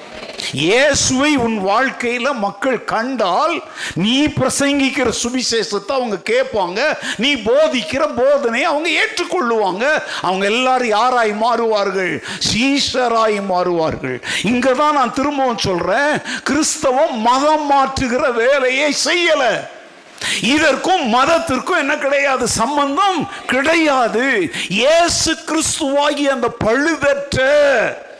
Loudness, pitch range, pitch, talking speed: -15 LUFS, 235-300 Hz, 270 Hz, 85 wpm